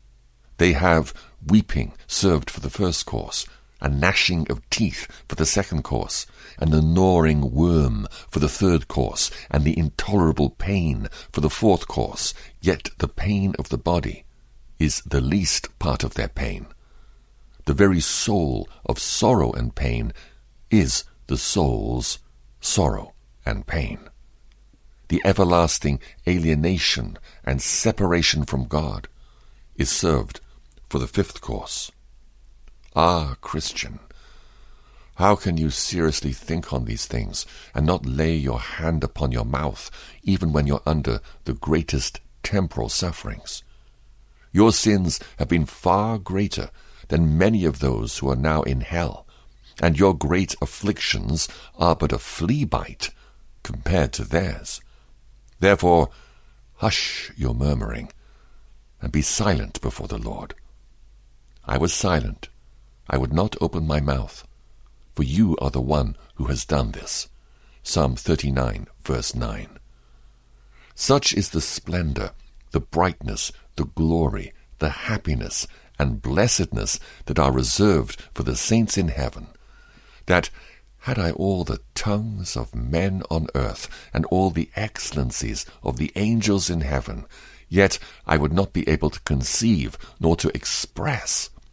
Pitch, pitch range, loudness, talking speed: 80 Hz, 70-95 Hz, -23 LUFS, 135 wpm